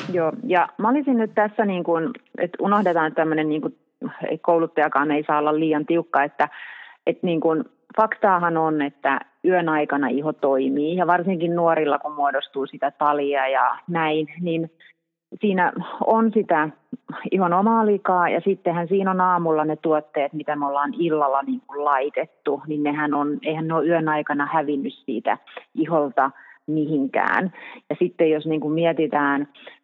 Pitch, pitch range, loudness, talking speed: 160 Hz, 145-175 Hz, -22 LUFS, 160 wpm